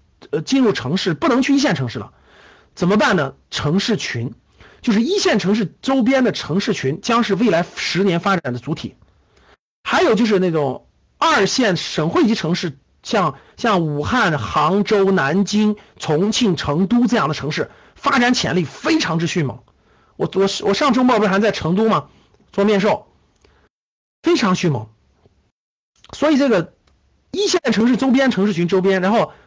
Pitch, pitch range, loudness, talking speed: 195 Hz, 160-225 Hz, -18 LUFS, 240 characters per minute